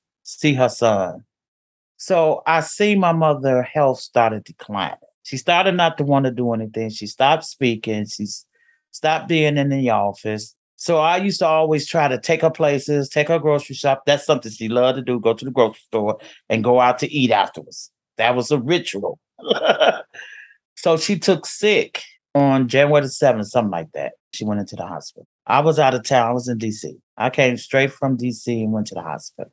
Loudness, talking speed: -19 LUFS, 200 wpm